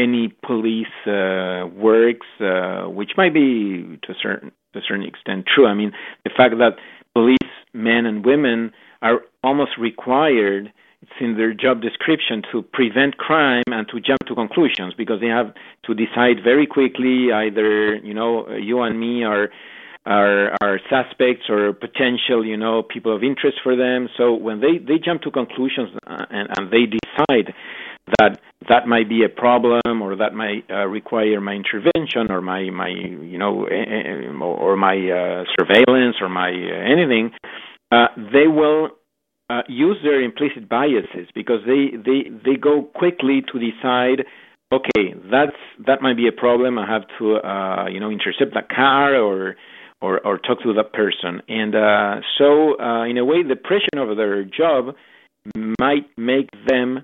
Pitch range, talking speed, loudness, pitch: 105-130 Hz, 170 wpm, -18 LUFS, 115 Hz